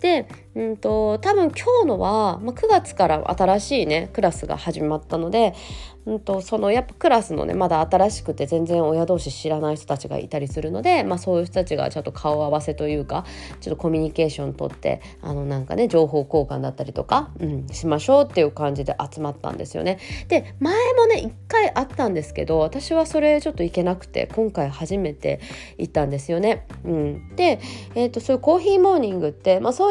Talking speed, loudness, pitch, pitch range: 425 characters per minute, -22 LUFS, 175 Hz, 150-240 Hz